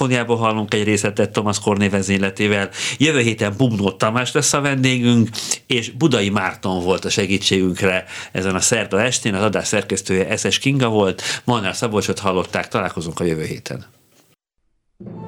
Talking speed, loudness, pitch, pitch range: 145 wpm, -18 LUFS, 105 Hz, 95-120 Hz